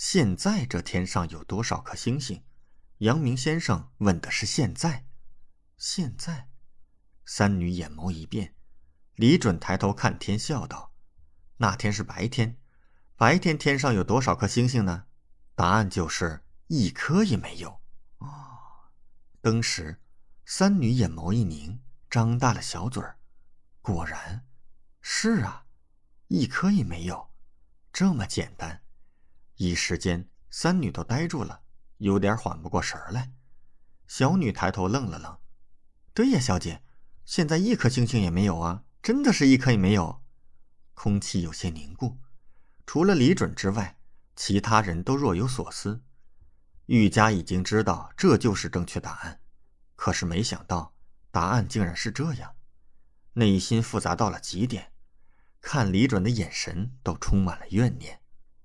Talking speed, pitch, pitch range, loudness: 205 characters per minute, 100 Hz, 85-120 Hz, -26 LUFS